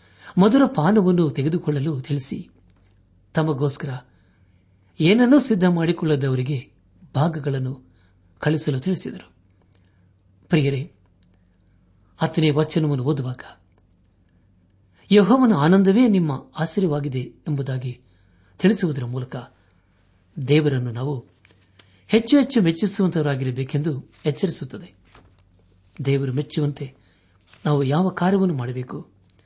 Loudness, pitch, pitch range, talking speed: -21 LUFS, 135 Hz, 95-160 Hz, 70 wpm